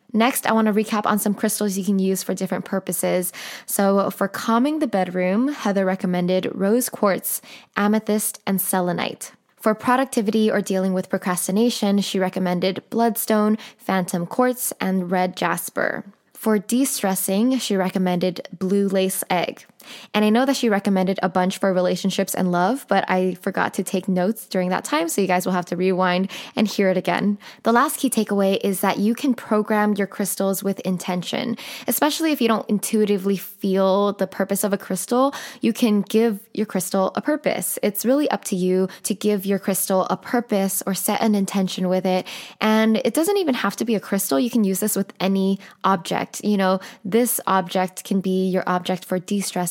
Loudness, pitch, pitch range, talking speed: -21 LUFS, 200 Hz, 190-220 Hz, 185 wpm